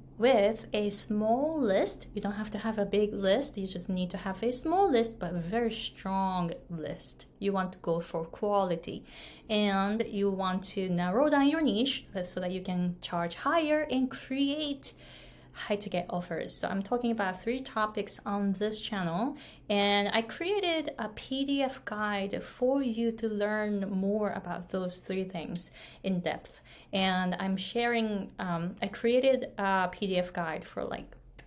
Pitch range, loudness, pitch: 185-235 Hz, -31 LUFS, 205 Hz